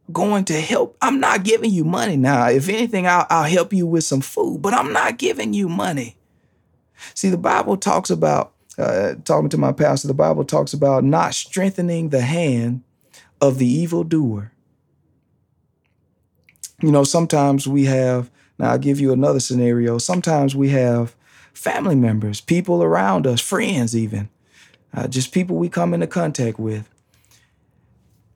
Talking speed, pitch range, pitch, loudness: 160 wpm, 120-170 Hz, 140 Hz, -18 LUFS